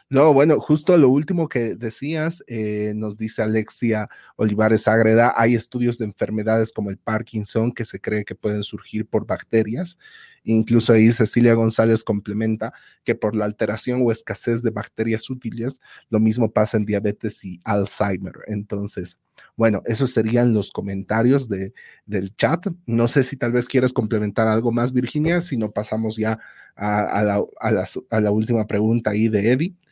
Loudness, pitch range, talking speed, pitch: -21 LUFS, 105-120 Hz, 170 wpm, 110 Hz